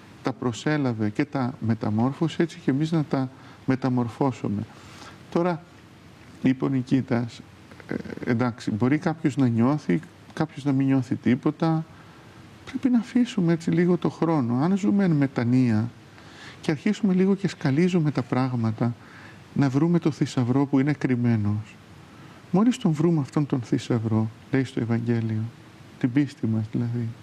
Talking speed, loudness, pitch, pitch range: 140 wpm, -25 LUFS, 135 Hz, 120-160 Hz